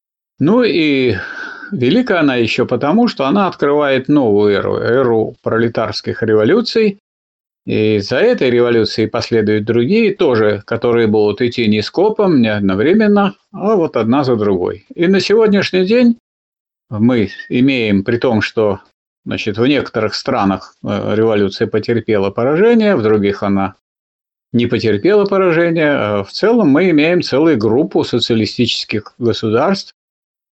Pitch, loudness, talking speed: 120 Hz, -14 LUFS, 130 wpm